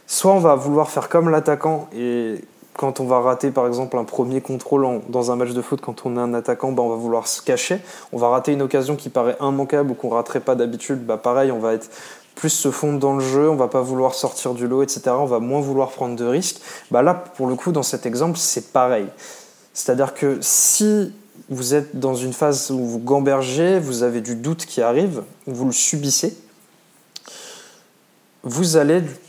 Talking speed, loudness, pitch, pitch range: 215 wpm, -19 LUFS, 135 Hz, 125-150 Hz